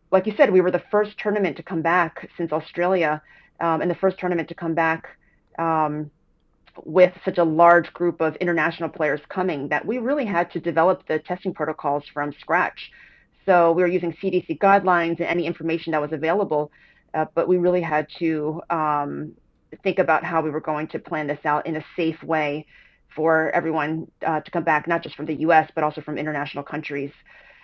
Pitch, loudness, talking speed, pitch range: 165 Hz, -22 LUFS, 200 wpm, 155-180 Hz